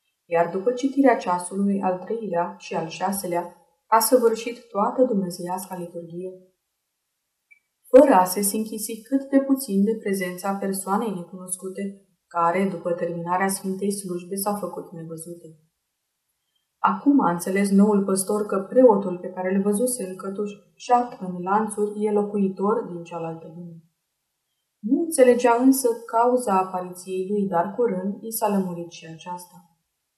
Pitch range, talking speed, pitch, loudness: 180-220 Hz, 135 wpm, 195 Hz, -23 LUFS